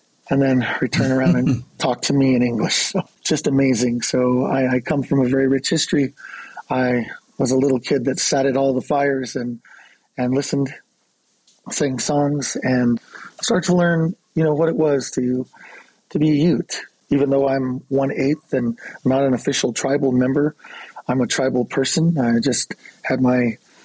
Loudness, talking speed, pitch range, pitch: -19 LUFS, 180 wpm, 125-145 Hz, 135 Hz